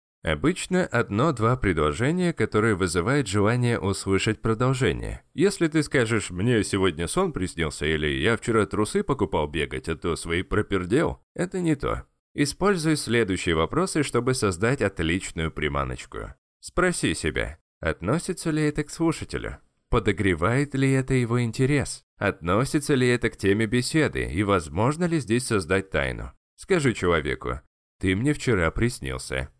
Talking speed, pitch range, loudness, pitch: 130 wpm, 90-145 Hz, -25 LUFS, 110 Hz